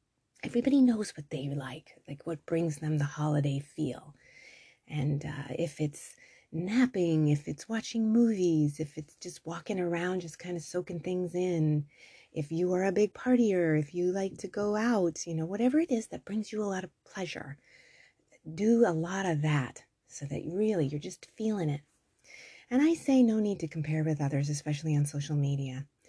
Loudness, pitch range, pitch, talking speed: -31 LUFS, 150-205 Hz, 170 Hz, 185 wpm